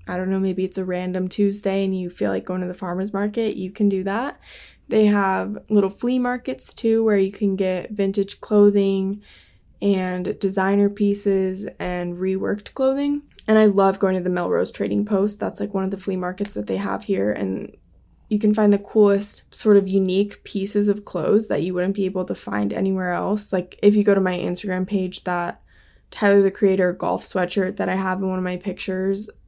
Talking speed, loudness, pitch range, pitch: 210 wpm, -21 LUFS, 185-205 Hz, 195 Hz